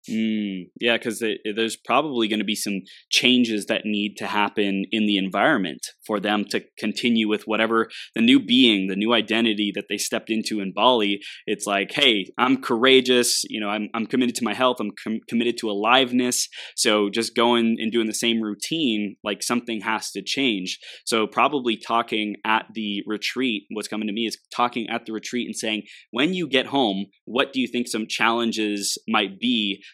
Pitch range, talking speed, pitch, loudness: 105-120 Hz, 190 wpm, 110 Hz, -22 LUFS